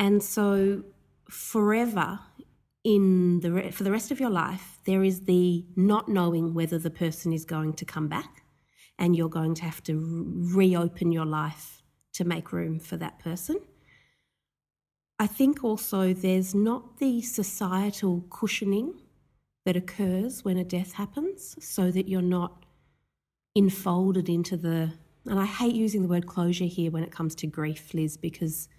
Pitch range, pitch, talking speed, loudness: 165-200 Hz, 185 Hz, 160 wpm, -27 LUFS